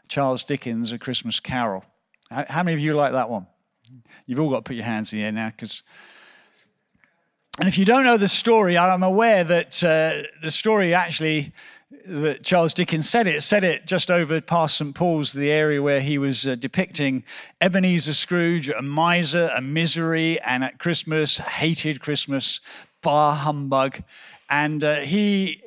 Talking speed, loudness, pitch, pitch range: 170 wpm, -21 LUFS, 155 Hz, 135-175 Hz